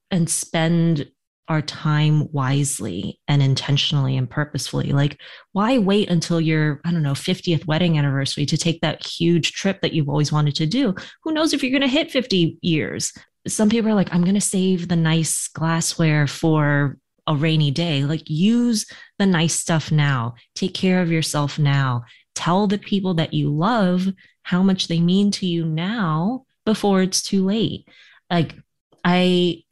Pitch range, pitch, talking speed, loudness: 150-190 Hz, 165 Hz, 170 wpm, -20 LUFS